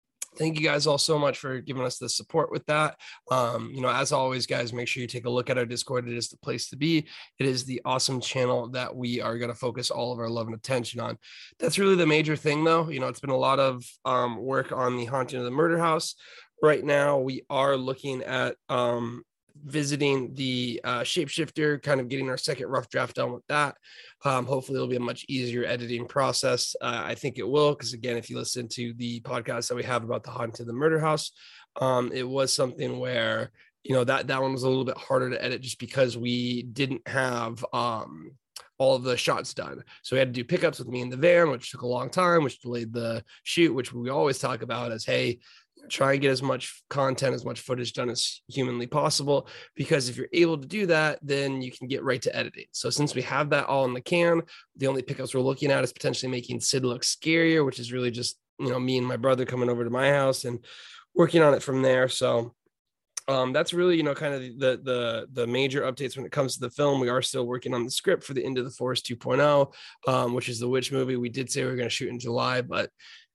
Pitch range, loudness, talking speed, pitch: 125-140 Hz, -27 LUFS, 245 wpm, 130 Hz